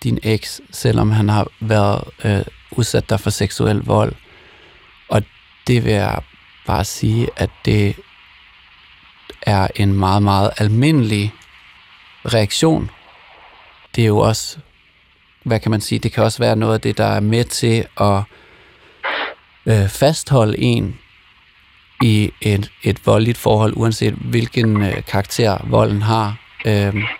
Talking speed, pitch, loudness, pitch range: 135 wpm, 110 Hz, -17 LUFS, 100-115 Hz